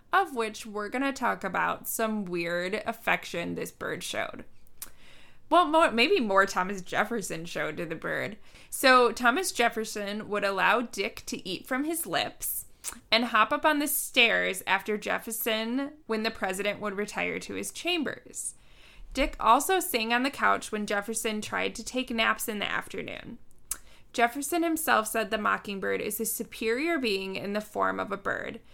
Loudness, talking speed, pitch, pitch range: -28 LUFS, 165 wpm, 225 Hz, 210-255 Hz